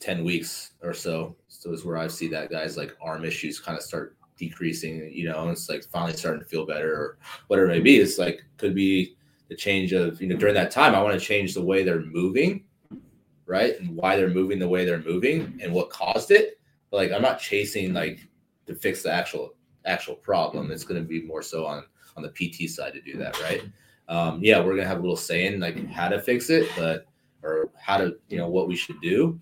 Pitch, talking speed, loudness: 90 Hz, 235 wpm, -25 LUFS